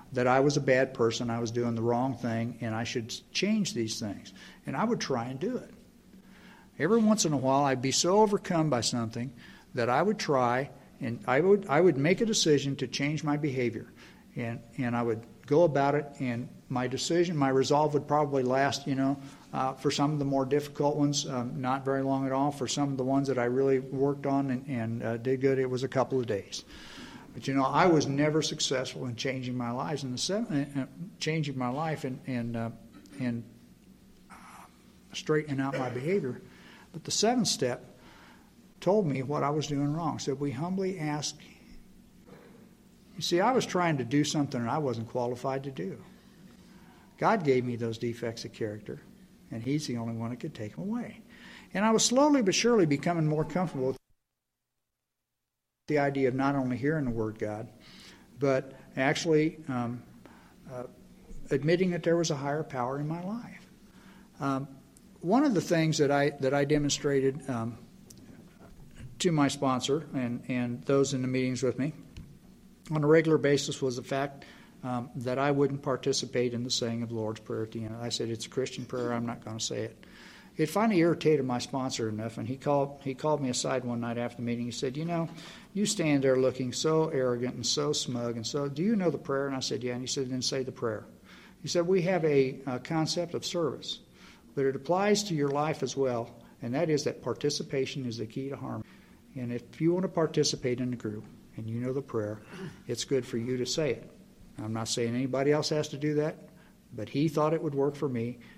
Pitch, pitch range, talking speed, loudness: 135 Hz, 125-155 Hz, 210 wpm, -30 LUFS